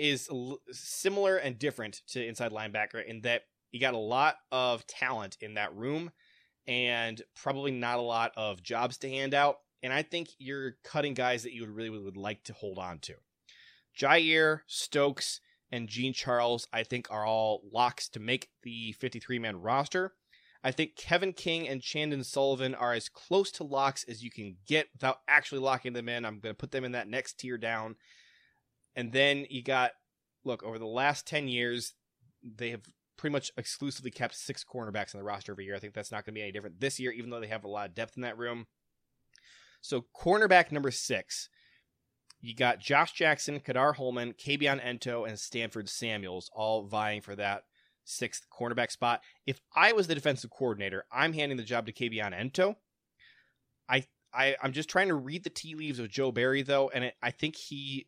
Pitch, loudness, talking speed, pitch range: 125 Hz, -32 LUFS, 195 wpm, 115-140 Hz